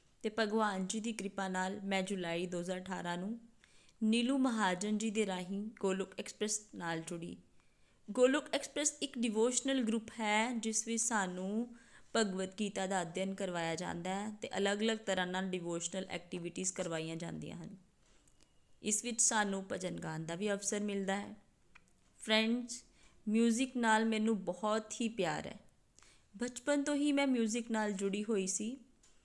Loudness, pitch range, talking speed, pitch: -36 LUFS, 185-230 Hz, 145 wpm, 210 Hz